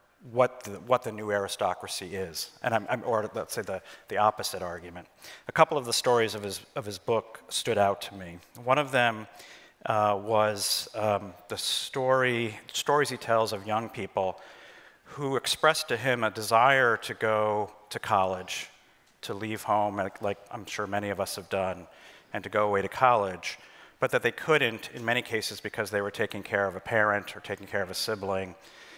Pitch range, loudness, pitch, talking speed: 100-110 Hz, -28 LUFS, 105 Hz, 195 wpm